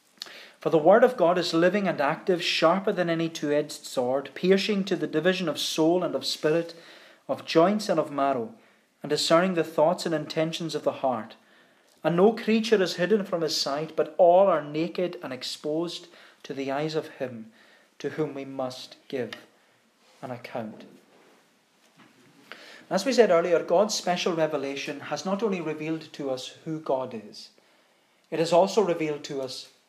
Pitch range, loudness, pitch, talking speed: 150-180 Hz, -26 LUFS, 160 Hz, 175 wpm